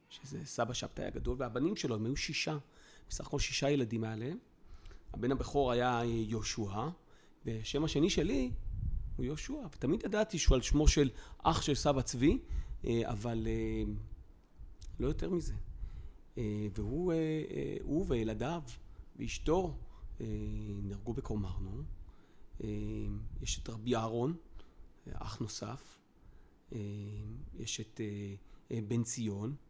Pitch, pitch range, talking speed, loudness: 115 Hz, 105-135 Hz, 105 wpm, -36 LUFS